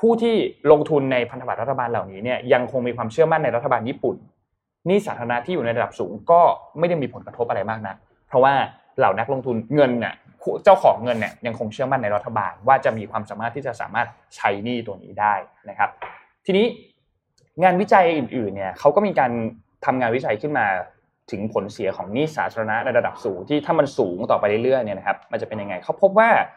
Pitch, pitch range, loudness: 125 Hz, 115-160 Hz, -21 LUFS